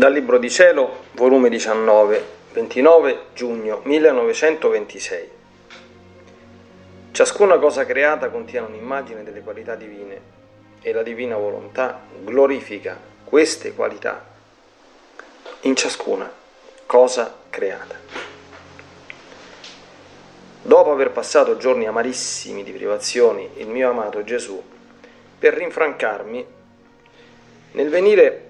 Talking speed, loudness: 90 wpm, -18 LUFS